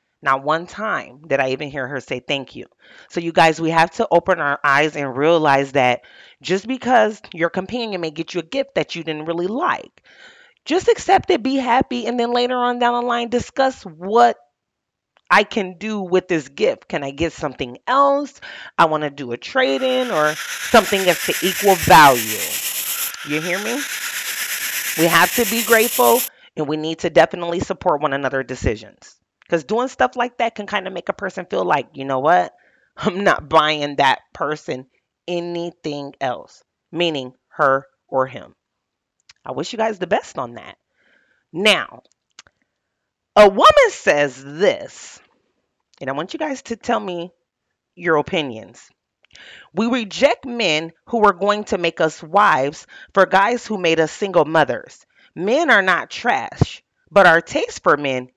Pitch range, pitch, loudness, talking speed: 150-235 Hz, 175 Hz, -18 LUFS, 175 wpm